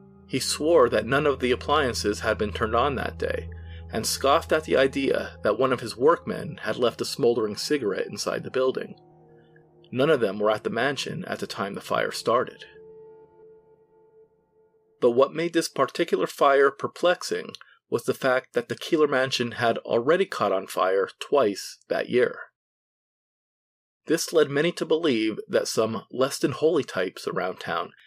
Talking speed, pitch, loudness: 170 wpm, 165 Hz, -25 LUFS